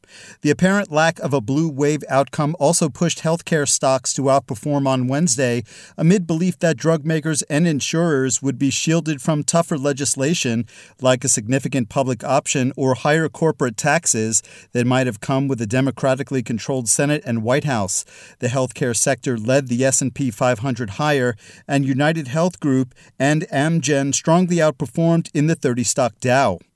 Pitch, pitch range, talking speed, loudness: 140 Hz, 130-160 Hz, 160 wpm, -19 LUFS